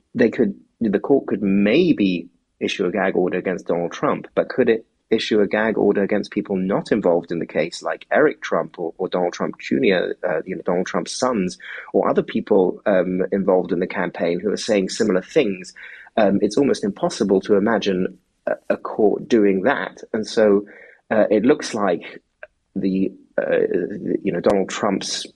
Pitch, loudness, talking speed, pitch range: 105 Hz, -20 LUFS, 180 wpm, 100-145 Hz